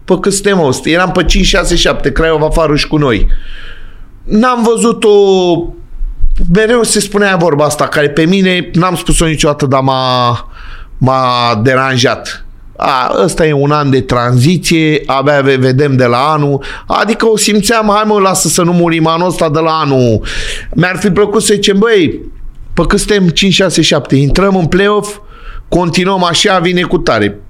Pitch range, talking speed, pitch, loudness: 140-195 Hz, 155 wpm, 170 Hz, -10 LUFS